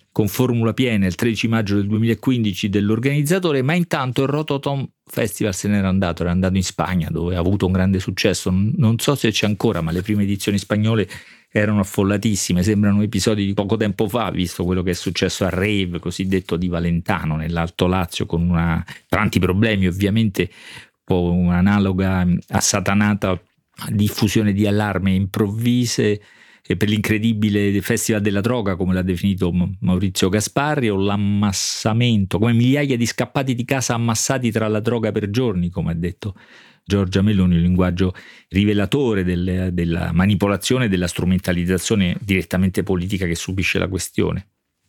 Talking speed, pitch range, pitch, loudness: 155 wpm, 90-110 Hz, 100 Hz, -19 LUFS